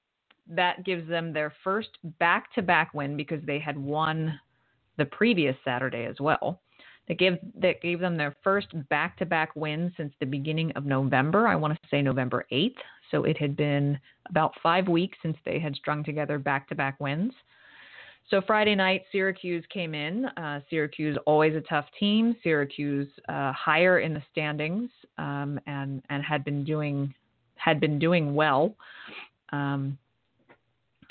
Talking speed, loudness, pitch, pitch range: 165 wpm, -27 LUFS, 155 Hz, 145-175 Hz